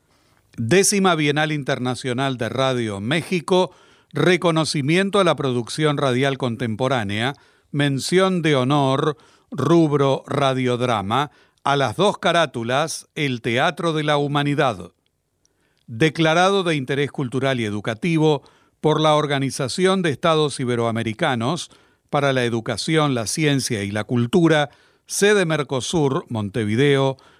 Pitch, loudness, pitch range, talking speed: 145 Hz, -20 LUFS, 125-160 Hz, 105 wpm